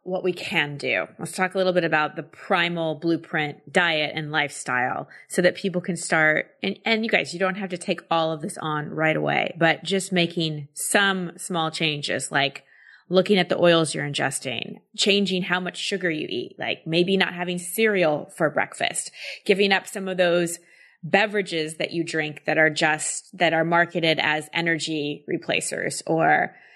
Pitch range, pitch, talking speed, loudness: 155-185 Hz, 170 Hz, 180 wpm, -23 LUFS